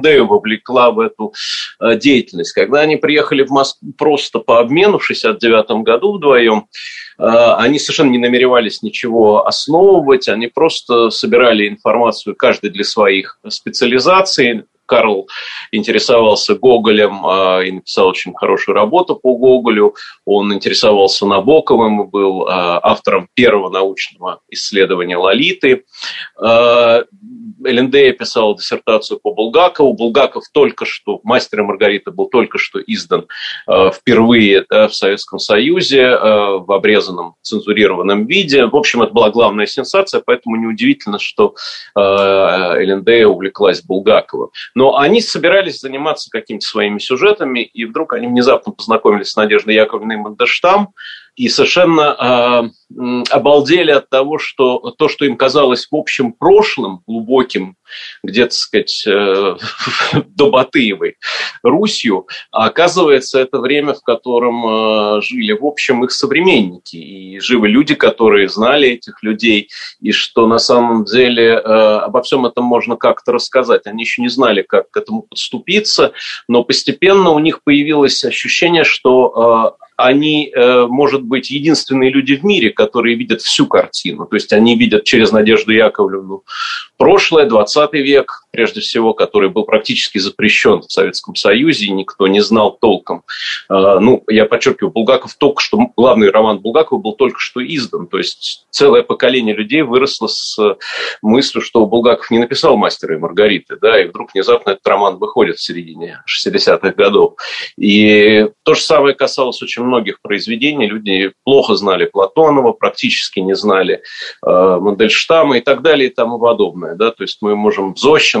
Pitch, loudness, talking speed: 125 Hz, -12 LUFS, 140 wpm